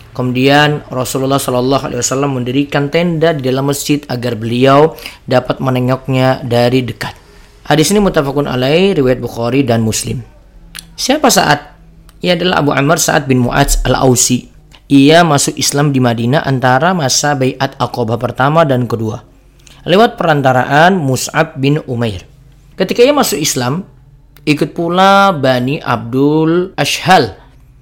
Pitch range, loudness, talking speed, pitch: 125-150 Hz, -12 LUFS, 130 wpm, 135 Hz